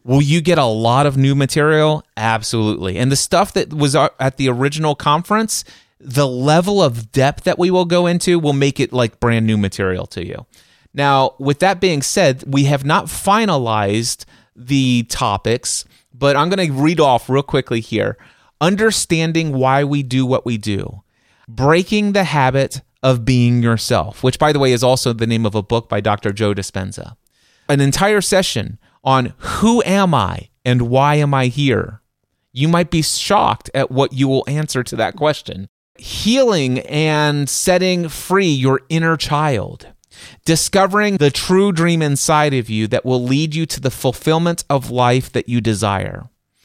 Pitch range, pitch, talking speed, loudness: 120-155 Hz, 135 Hz, 170 wpm, -16 LUFS